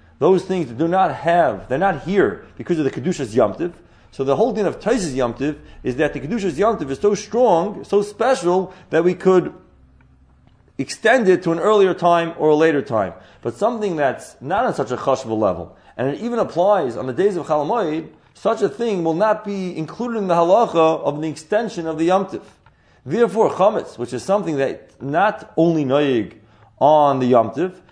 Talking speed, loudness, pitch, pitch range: 190 wpm, -19 LUFS, 170 Hz, 145-200 Hz